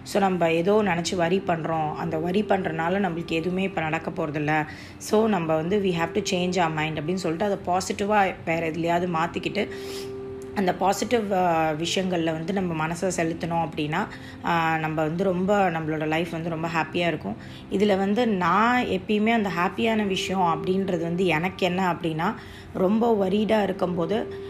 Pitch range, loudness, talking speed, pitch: 165-195 Hz, -24 LUFS, 155 wpm, 180 Hz